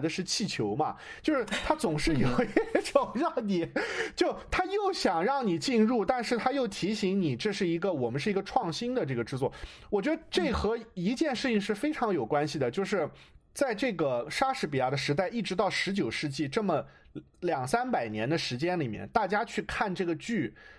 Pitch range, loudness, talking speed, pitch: 170-265 Hz, -30 LUFS, 285 characters per minute, 210 Hz